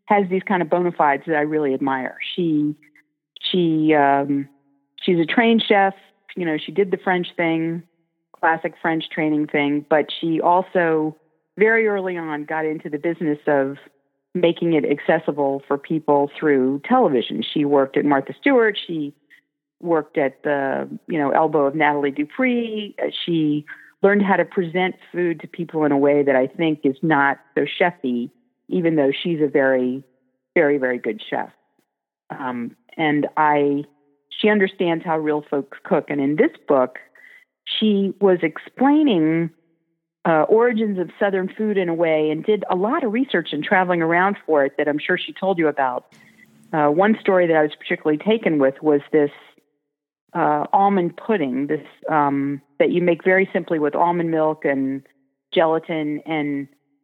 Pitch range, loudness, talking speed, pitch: 145-180 Hz, -20 LUFS, 165 wpm, 160 Hz